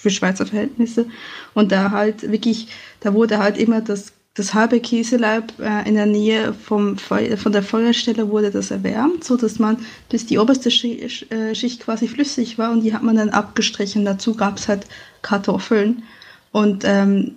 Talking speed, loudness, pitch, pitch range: 185 wpm, -19 LUFS, 220 Hz, 210-235 Hz